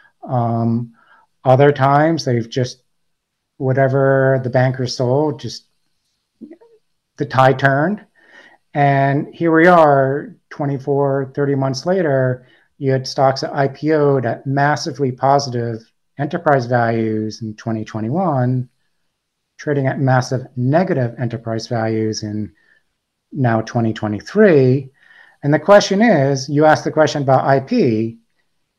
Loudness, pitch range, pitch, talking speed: -16 LUFS, 120-145 Hz, 135 Hz, 110 wpm